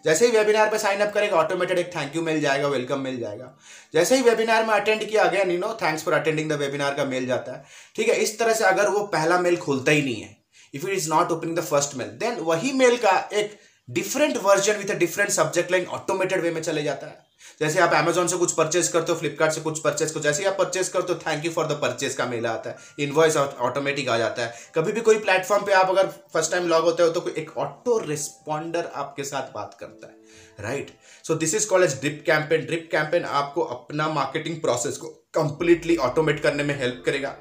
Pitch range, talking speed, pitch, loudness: 150-195 Hz, 240 wpm, 165 Hz, -23 LUFS